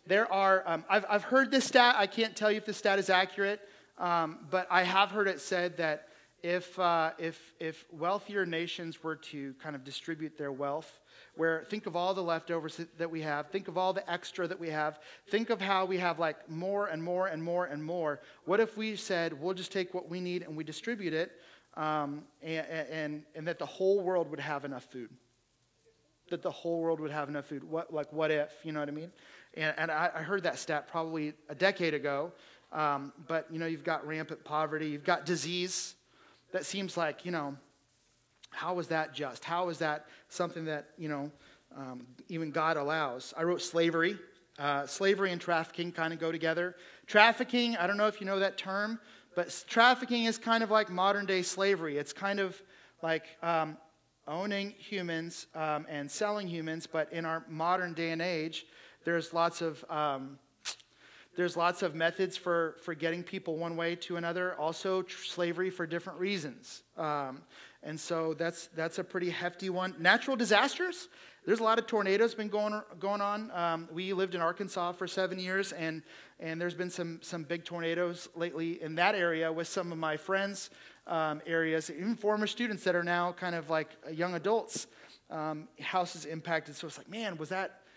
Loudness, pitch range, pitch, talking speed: -33 LUFS, 160-190 Hz, 170 Hz, 195 wpm